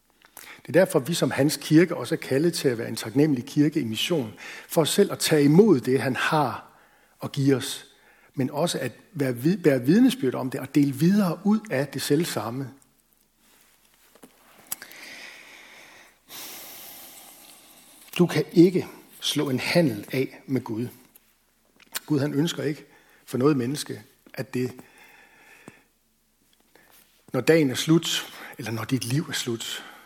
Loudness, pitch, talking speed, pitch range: -24 LUFS, 145 Hz, 150 wpm, 130-165 Hz